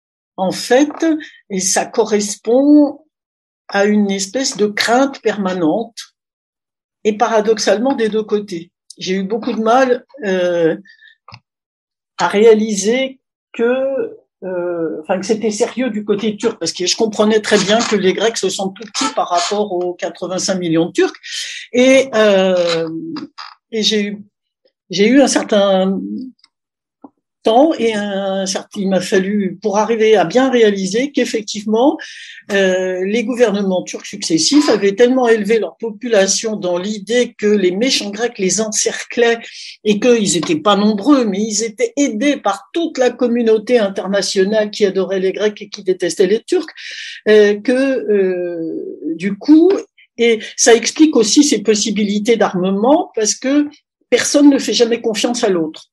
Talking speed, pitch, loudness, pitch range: 145 wpm, 220 Hz, -15 LUFS, 195-255 Hz